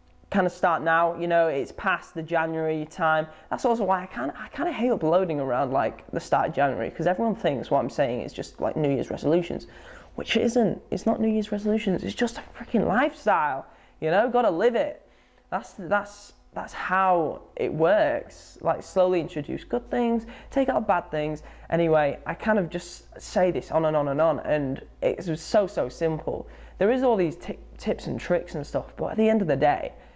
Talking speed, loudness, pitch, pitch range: 215 wpm, -25 LUFS, 185 Hz, 160-220 Hz